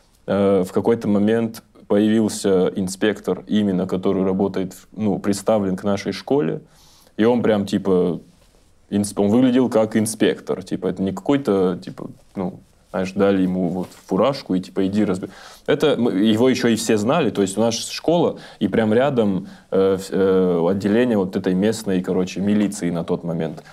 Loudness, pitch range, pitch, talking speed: -20 LUFS, 95-105 Hz, 100 Hz, 160 wpm